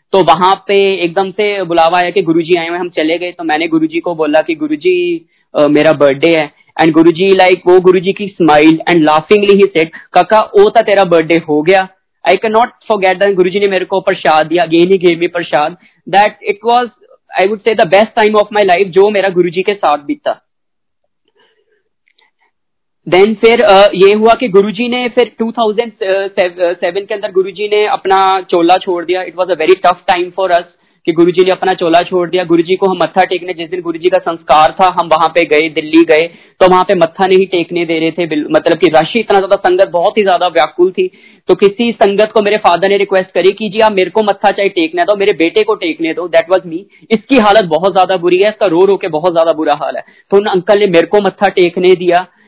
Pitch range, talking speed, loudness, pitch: 175-215 Hz, 215 wpm, -10 LUFS, 190 Hz